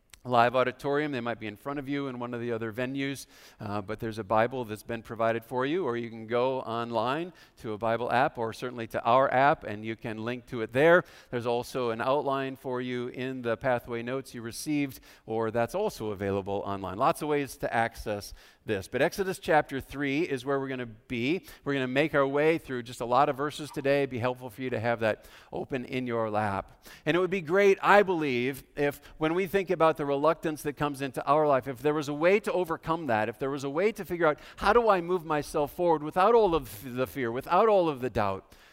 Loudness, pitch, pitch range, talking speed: -29 LUFS, 130 Hz, 115-150 Hz, 240 wpm